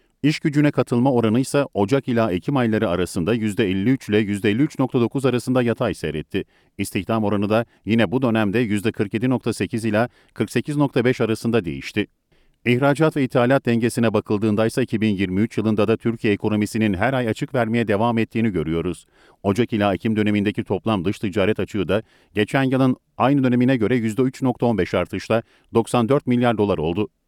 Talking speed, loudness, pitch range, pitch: 145 wpm, -21 LUFS, 105-125 Hz, 115 Hz